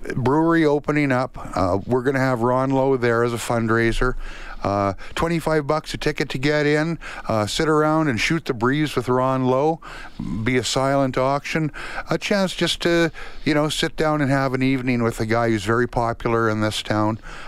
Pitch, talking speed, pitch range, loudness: 135 Hz, 195 wpm, 115-155 Hz, -21 LUFS